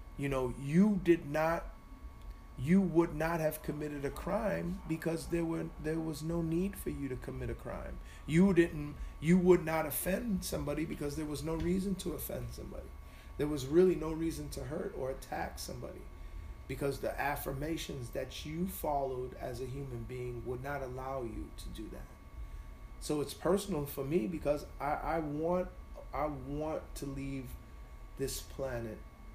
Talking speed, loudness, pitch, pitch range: 170 wpm, -35 LUFS, 145 Hz, 130-165 Hz